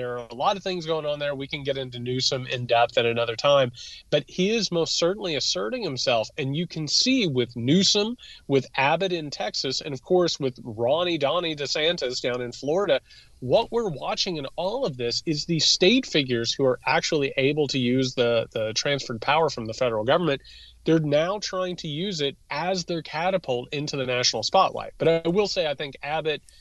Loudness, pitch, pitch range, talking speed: -24 LUFS, 145 Hz, 125-170 Hz, 205 wpm